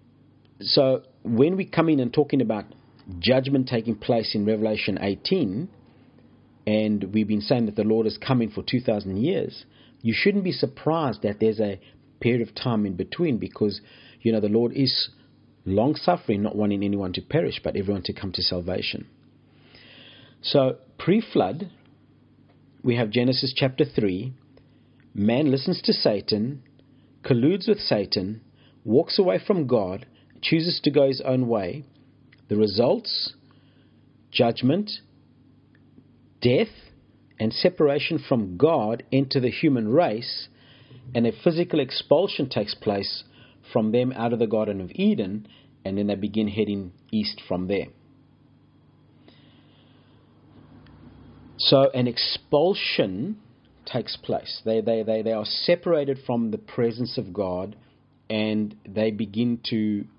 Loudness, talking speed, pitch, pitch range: -24 LUFS, 135 wpm, 125 Hz, 110-135 Hz